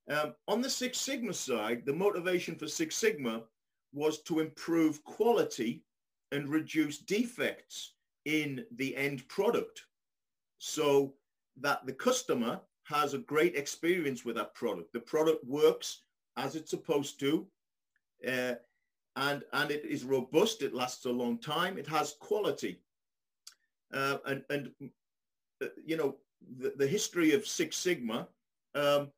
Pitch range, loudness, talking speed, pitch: 135-180 Hz, -33 LUFS, 135 wpm, 150 Hz